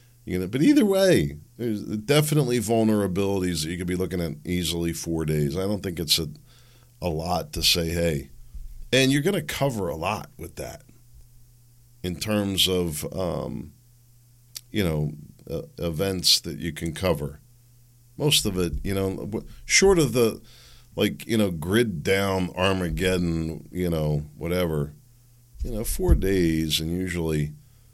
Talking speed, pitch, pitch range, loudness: 150 wpm, 95 Hz, 80-120 Hz, -24 LUFS